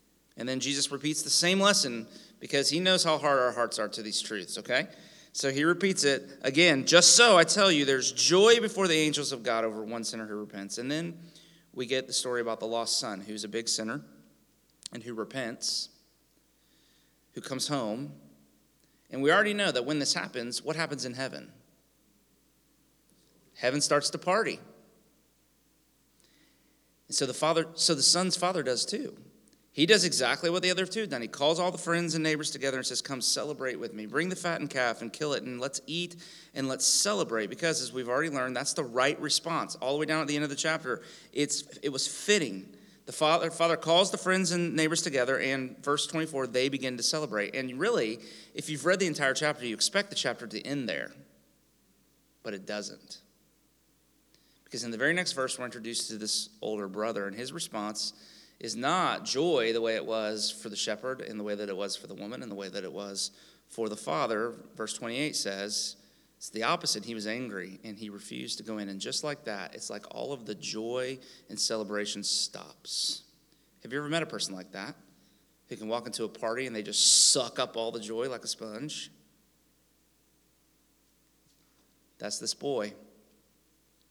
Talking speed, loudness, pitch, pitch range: 200 wpm, -28 LUFS, 130 Hz, 110-160 Hz